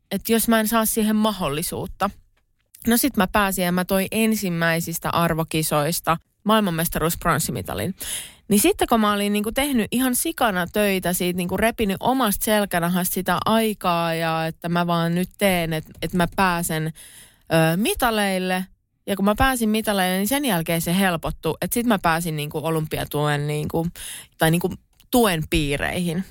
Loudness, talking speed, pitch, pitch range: -22 LUFS, 150 wpm, 185 Hz, 165-215 Hz